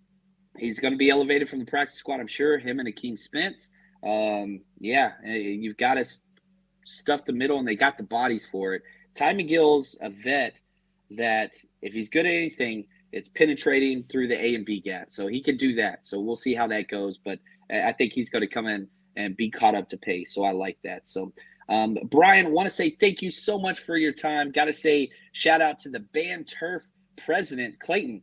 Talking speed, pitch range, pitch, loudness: 220 wpm, 110-165 Hz, 140 Hz, -25 LUFS